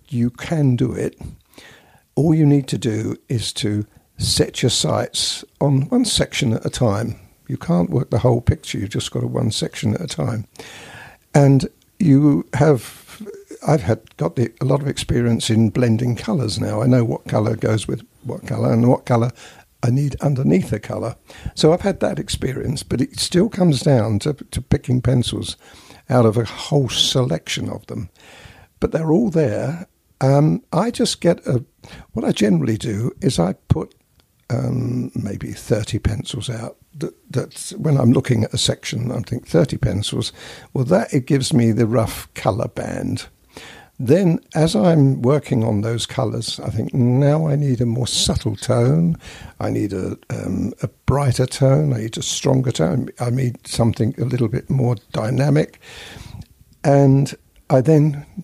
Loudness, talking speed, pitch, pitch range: -19 LUFS, 175 wpm, 125 Hz, 115-145 Hz